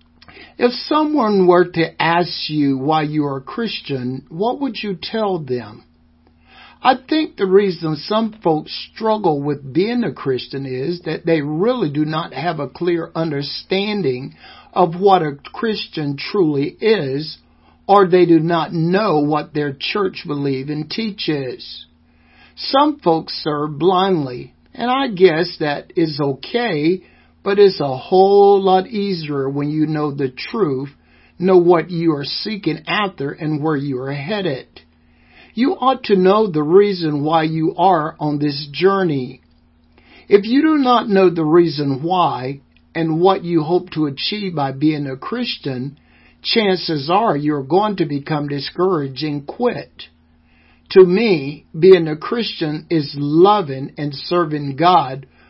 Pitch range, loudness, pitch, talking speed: 140-190 Hz, -17 LUFS, 160 Hz, 145 wpm